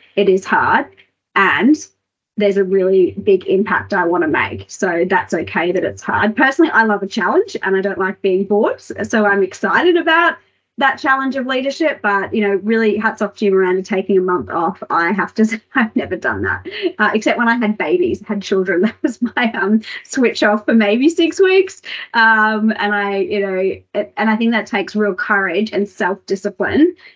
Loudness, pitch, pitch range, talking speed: -16 LUFS, 210 Hz, 195-245 Hz, 205 wpm